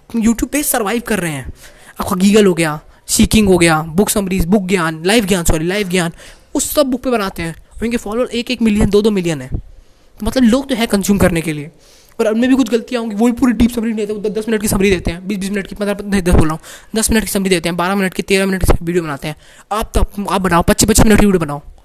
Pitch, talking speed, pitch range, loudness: 205 Hz, 265 wpm, 180-230 Hz, -15 LUFS